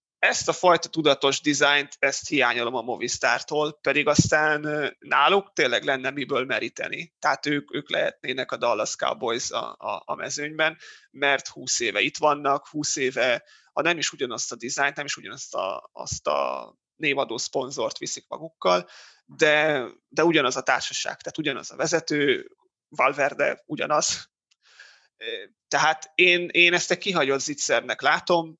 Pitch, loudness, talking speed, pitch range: 155 Hz, -24 LUFS, 145 wpm, 145-175 Hz